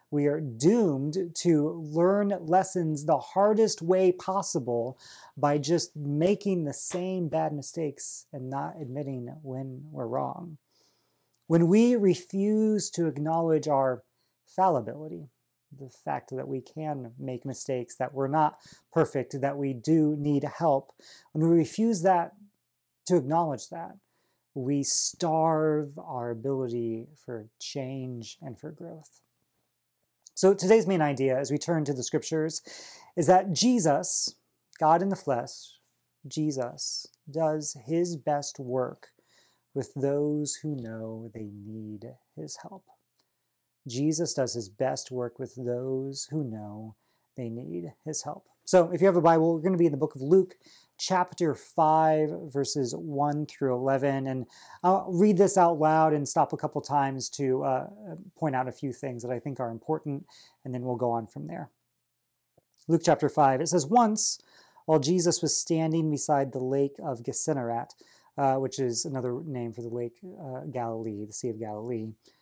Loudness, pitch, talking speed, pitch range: -28 LUFS, 145 Hz, 155 wpm, 130-165 Hz